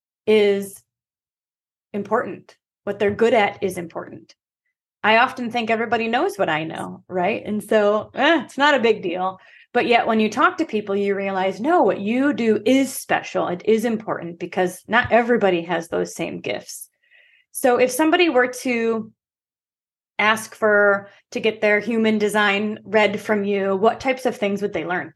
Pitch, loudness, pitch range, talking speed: 215 Hz, -20 LUFS, 200-245 Hz, 170 wpm